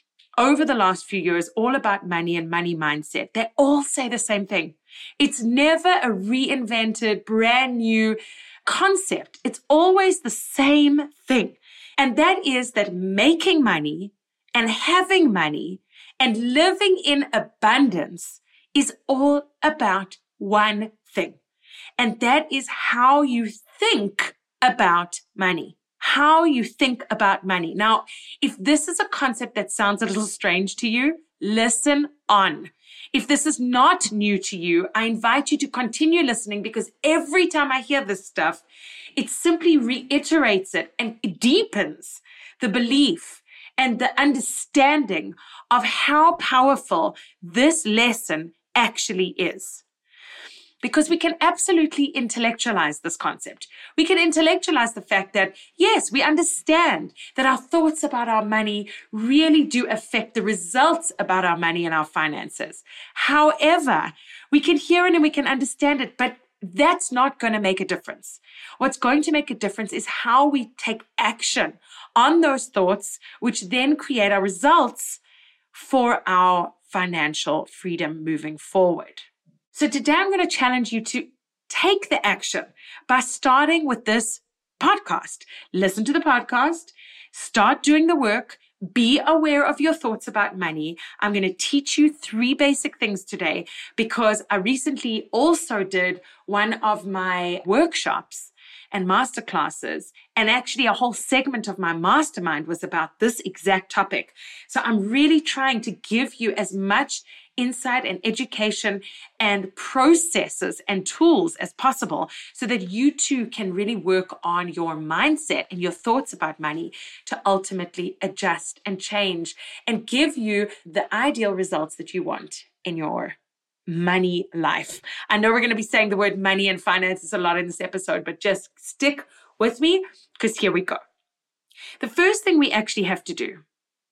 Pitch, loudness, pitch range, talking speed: 240 Hz, -21 LUFS, 200-290 Hz, 150 wpm